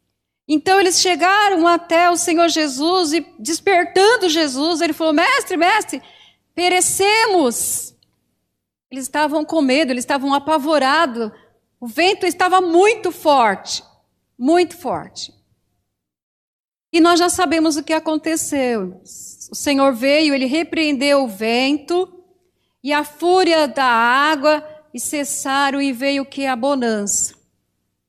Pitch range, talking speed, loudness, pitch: 280-350 Hz, 120 wpm, -16 LUFS, 315 Hz